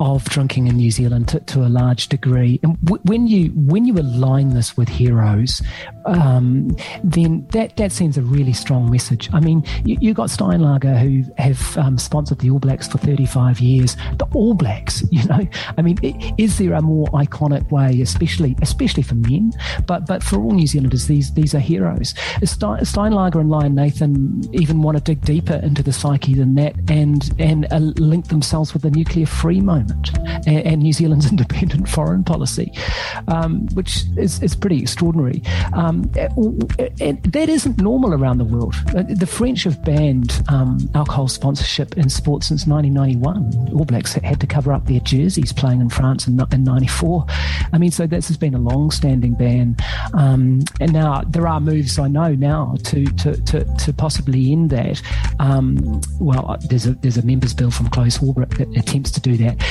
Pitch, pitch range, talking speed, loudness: 140 Hz, 125-160 Hz, 190 wpm, -17 LUFS